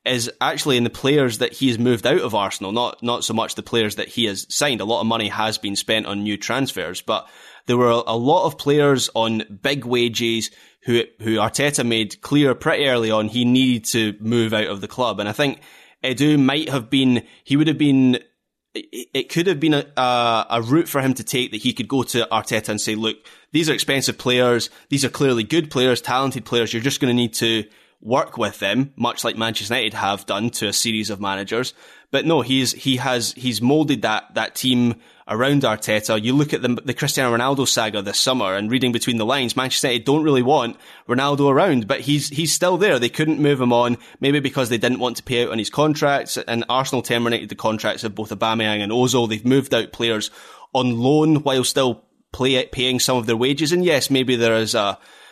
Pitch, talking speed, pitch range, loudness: 125 Hz, 220 wpm, 115-135 Hz, -19 LUFS